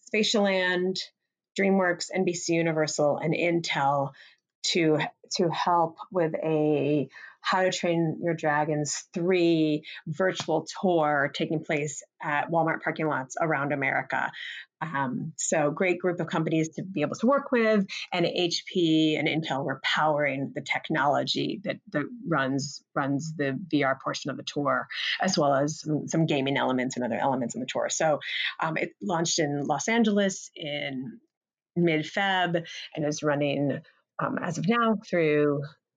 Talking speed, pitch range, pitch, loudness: 145 wpm, 150-180 Hz, 160 Hz, -27 LUFS